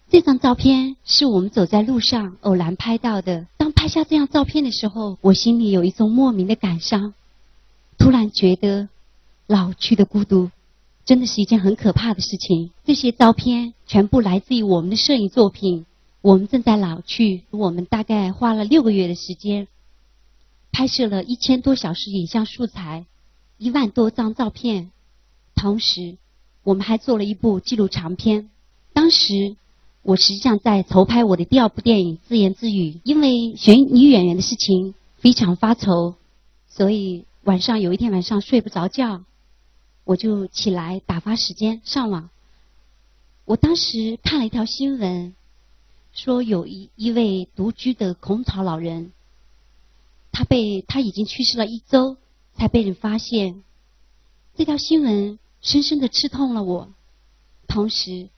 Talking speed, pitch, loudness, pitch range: 235 characters per minute, 205 Hz, -18 LUFS, 180-235 Hz